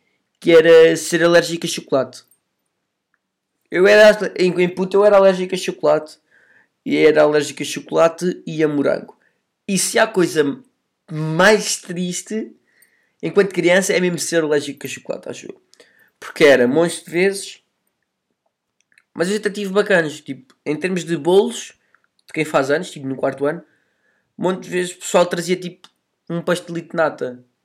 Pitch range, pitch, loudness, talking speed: 160-190 Hz, 175 Hz, -17 LUFS, 165 wpm